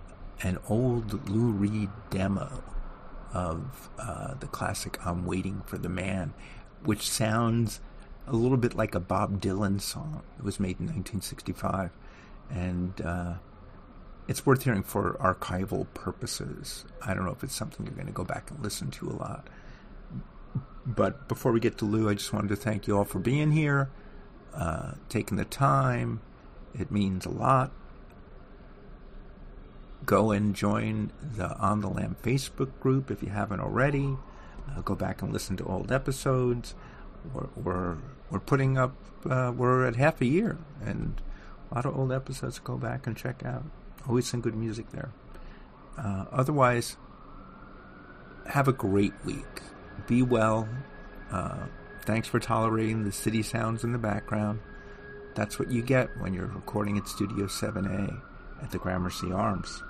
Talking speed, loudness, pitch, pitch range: 155 wpm, -30 LUFS, 110 Hz, 100-125 Hz